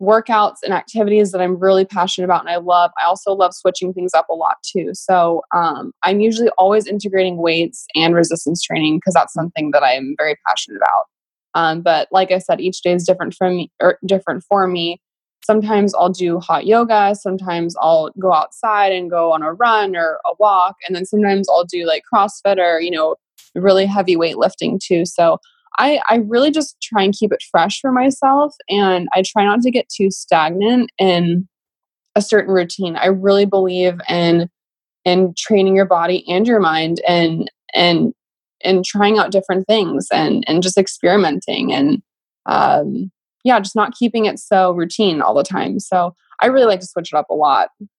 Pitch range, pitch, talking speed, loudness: 175-210 Hz, 185 Hz, 190 wpm, -16 LUFS